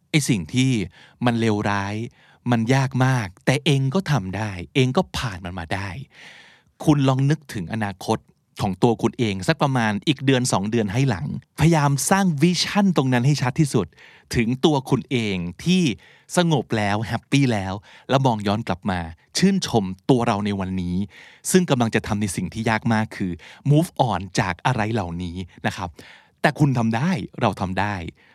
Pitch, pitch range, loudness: 120 Hz, 100-140 Hz, -22 LUFS